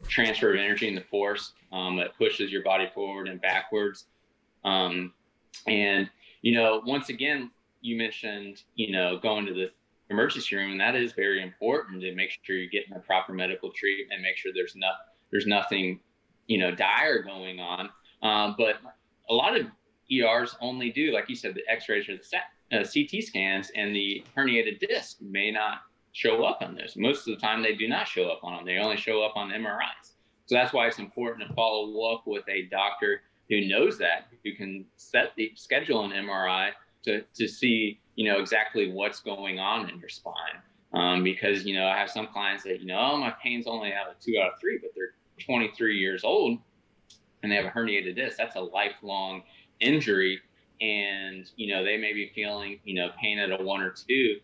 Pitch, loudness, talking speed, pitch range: 105 Hz, -28 LUFS, 205 wpm, 95-115 Hz